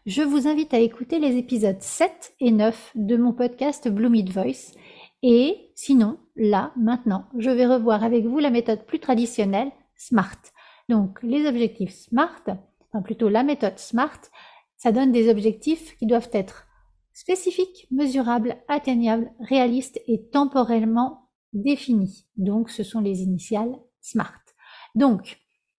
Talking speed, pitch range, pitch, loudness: 135 wpm, 220-270 Hz, 240 Hz, -23 LUFS